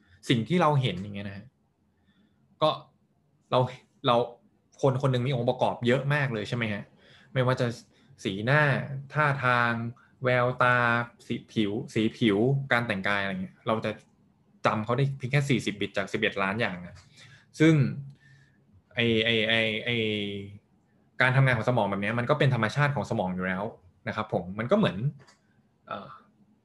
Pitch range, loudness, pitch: 105-135 Hz, -27 LUFS, 120 Hz